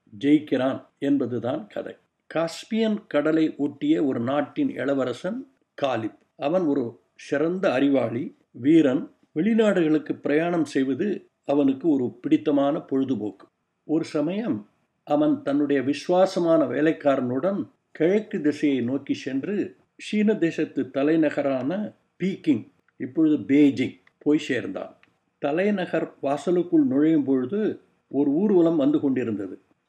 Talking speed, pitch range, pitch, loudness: 95 wpm, 140-220 Hz, 160 Hz, -24 LUFS